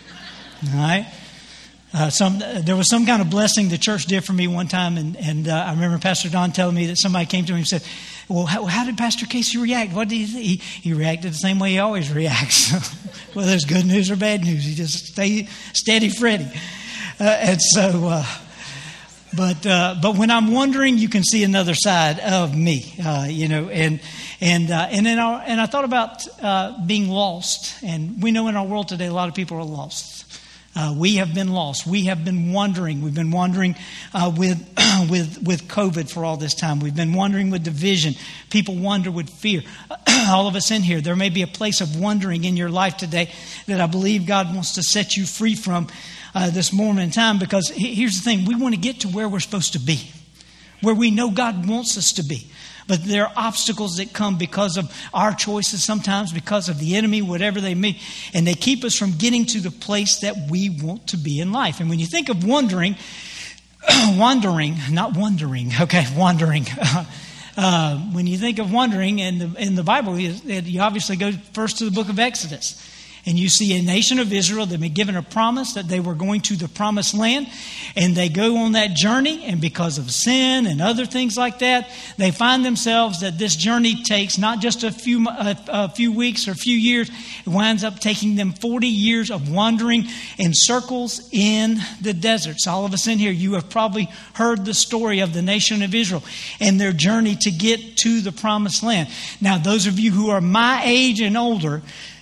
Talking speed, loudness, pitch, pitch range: 215 wpm, -19 LUFS, 195 Hz, 175-220 Hz